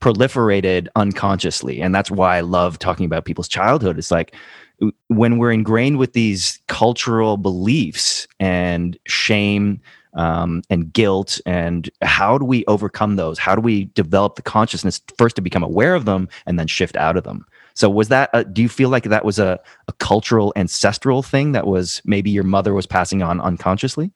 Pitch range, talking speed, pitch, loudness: 90-115 Hz, 180 wpm, 100 Hz, -17 LUFS